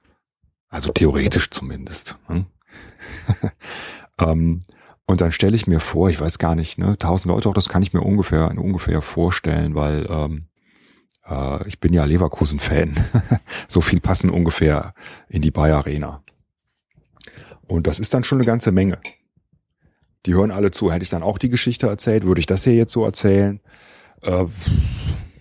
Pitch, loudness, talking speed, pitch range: 90 Hz, -19 LUFS, 155 wpm, 80-100 Hz